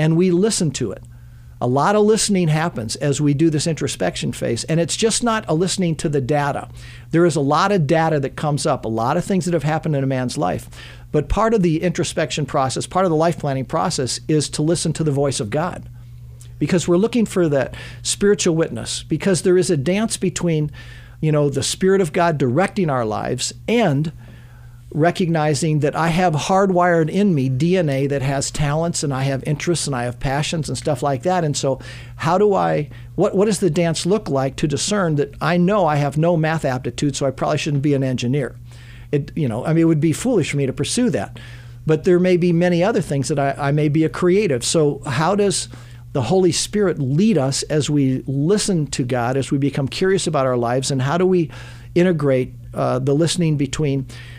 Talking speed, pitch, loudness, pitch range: 215 wpm, 150 Hz, -19 LUFS, 135-175 Hz